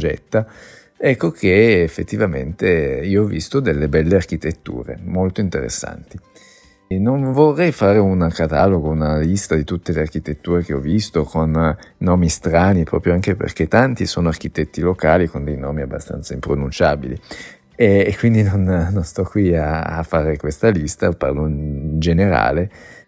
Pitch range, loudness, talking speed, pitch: 80-100 Hz, -18 LUFS, 150 wpm, 85 Hz